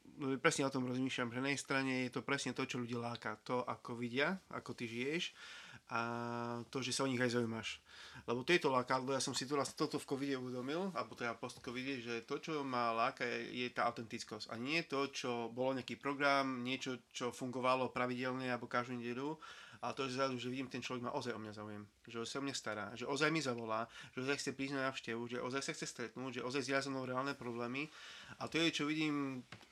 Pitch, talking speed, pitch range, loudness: 130 Hz, 220 wpm, 120-140 Hz, -40 LUFS